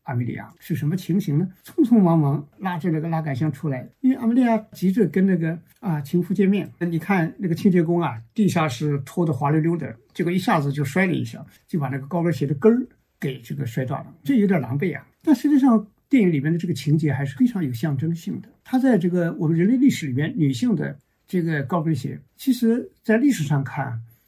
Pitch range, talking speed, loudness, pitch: 145-195 Hz, 340 characters per minute, -22 LUFS, 170 Hz